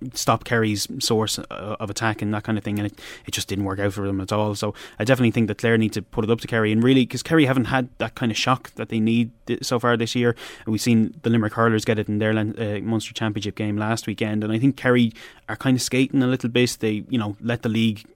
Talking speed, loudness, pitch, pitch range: 280 wpm, -22 LUFS, 115 Hz, 105-120 Hz